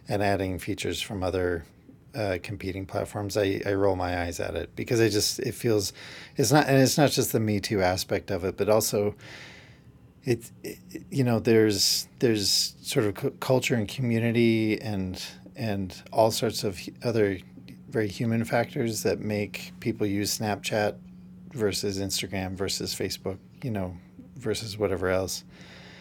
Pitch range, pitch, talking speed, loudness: 95-115 Hz, 105 Hz, 155 wpm, -27 LUFS